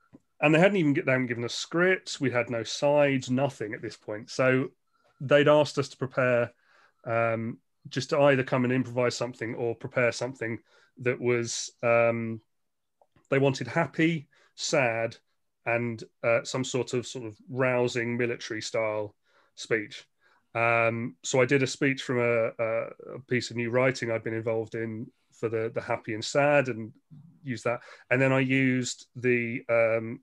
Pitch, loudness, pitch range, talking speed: 125 Hz, -27 LUFS, 115-135 Hz, 165 wpm